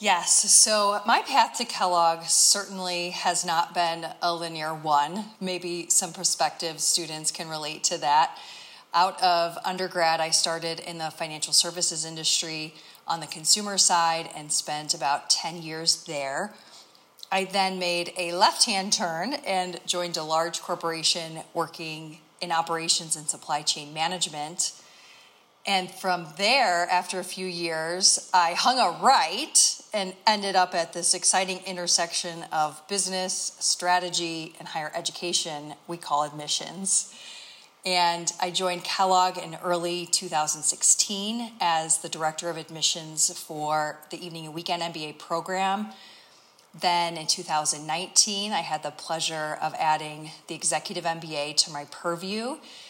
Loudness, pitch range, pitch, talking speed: -24 LUFS, 160-185 Hz, 170 Hz, 135 wpm